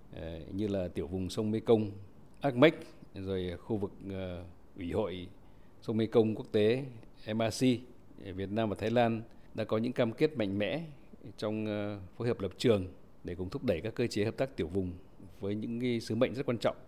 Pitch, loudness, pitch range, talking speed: 105 Hz, -33 LUFS, 95-120 Hz, 190 wpm